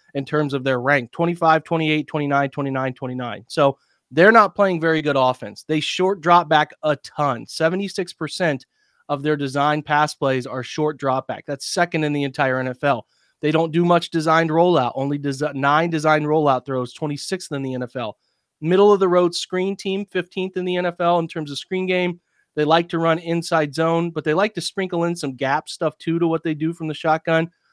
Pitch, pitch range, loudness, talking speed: 155 Hz, 140-170 Hz, -20 LUFS, 200 wpm